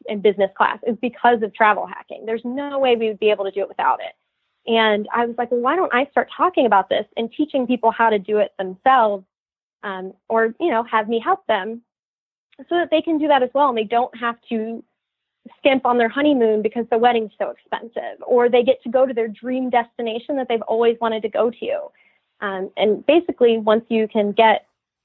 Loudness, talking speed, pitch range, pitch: -19 LUFS, 225 wpm, 220-260 Hz, 235 Hz